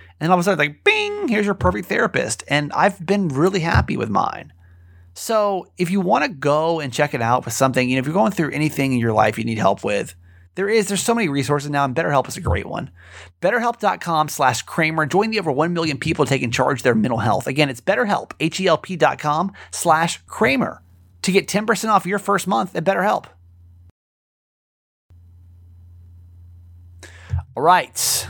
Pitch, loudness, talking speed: 145 Hz, -19 LUFS, 190 wpm